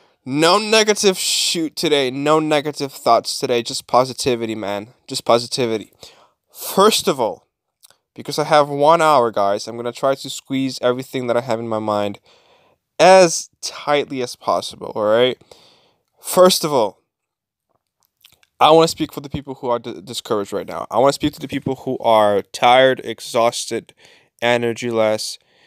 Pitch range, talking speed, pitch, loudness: 120-150 Hz, 160 wpm, 130 Hz, -17 LUFS